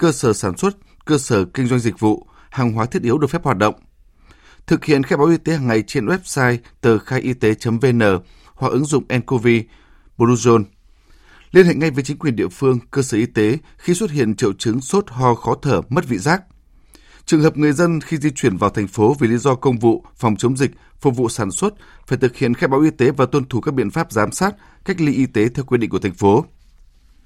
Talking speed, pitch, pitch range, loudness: 240 wpm, 125 Hz, 110-145 Hz, -18 LUFS